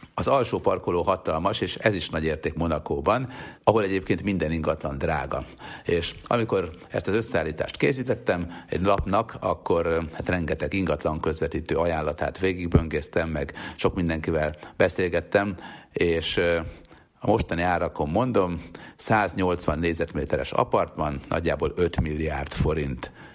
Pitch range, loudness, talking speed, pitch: 80-90 Hz, -26 LUFS, 120 wpm, 85 Hz